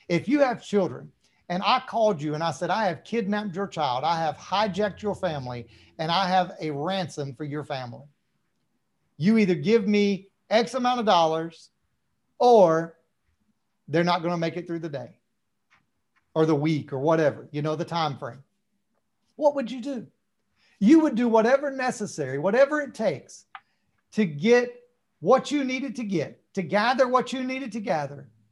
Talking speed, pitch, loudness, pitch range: 175 wpm, 195 Hz, -25 LUFS, 160-235 Hz